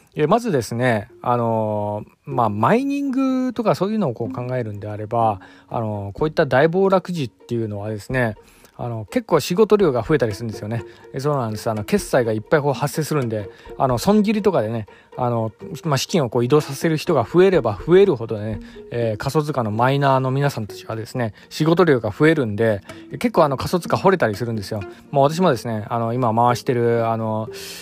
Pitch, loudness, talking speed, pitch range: 125 Hz, -20 LUFS, 410 characters per minute, 110-160 Hz